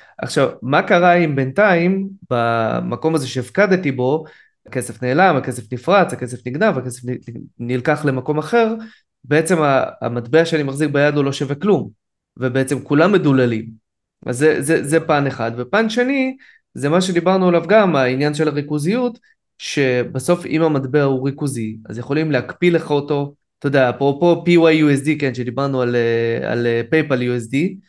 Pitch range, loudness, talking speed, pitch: 125-170 Hz, -17 LUFS, 145 wpm, 145 Hz